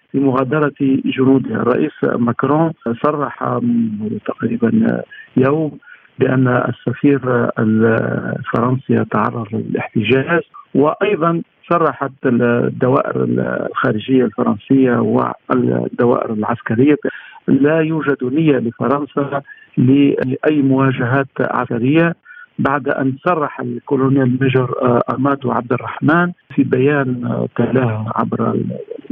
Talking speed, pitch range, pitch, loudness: 80 wpm, 120-145 Hz, 135 Hz, -16 LUFS